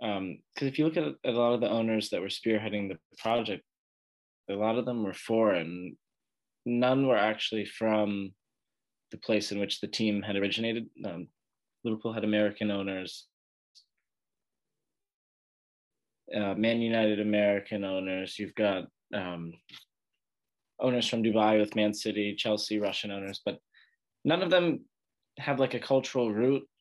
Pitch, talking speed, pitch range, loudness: 110 Hz, 150 wpm, 100-120 Hz, -30 LUFS